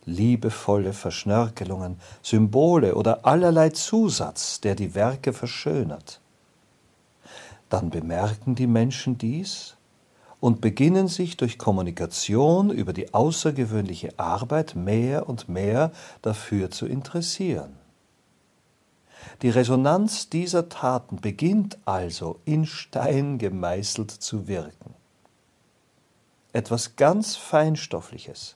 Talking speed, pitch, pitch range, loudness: 90 wpm, 120 Hz, 100-155 Hz, -24 LUFS